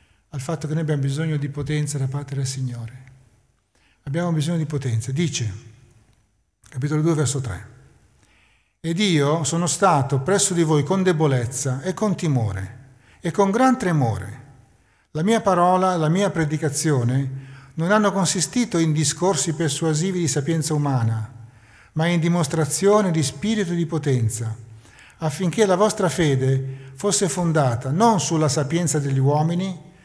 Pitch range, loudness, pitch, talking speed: 130-170 Hz, -21 LUFS, 150 Hz, 140 wpm